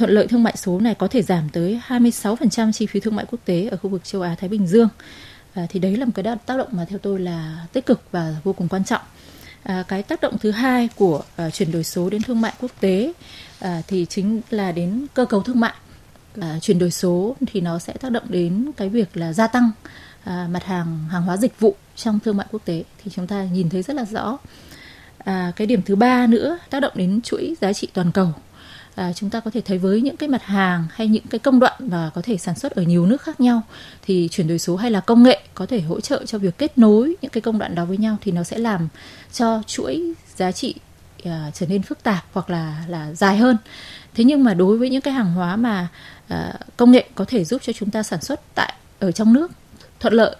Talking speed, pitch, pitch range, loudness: 250 wpm, 205 Hz, 180-235 Hz, -20 LUFS